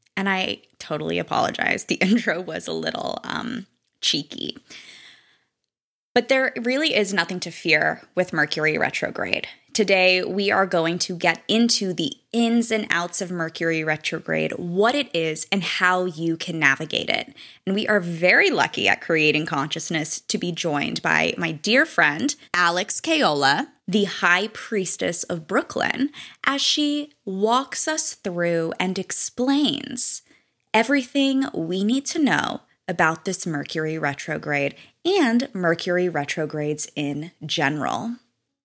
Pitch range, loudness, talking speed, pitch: 165-235 Hz, -22 LUFS, 135 wpm, 185 Hz